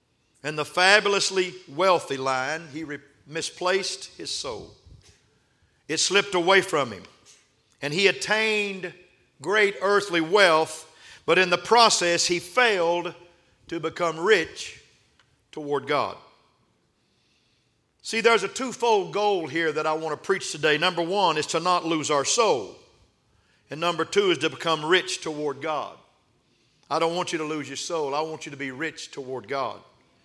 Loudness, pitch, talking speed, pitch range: -23 LUFS, 165 Hz, 155 wpm, 155-190 Hz